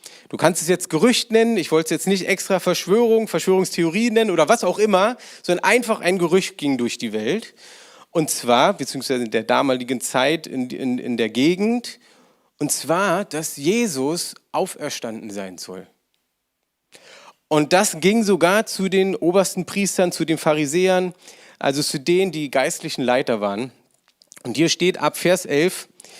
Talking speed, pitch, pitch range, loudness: 160 wpm, 170 Hz, 135-190 Hz, -20 LUFS